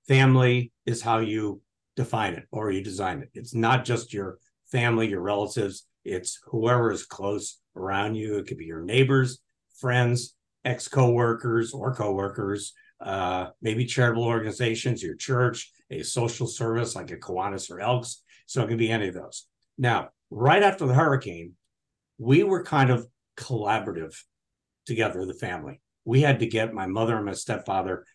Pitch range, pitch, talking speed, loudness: 105-125 Hz, 115 Hz, 165 wpm, -26 LUFS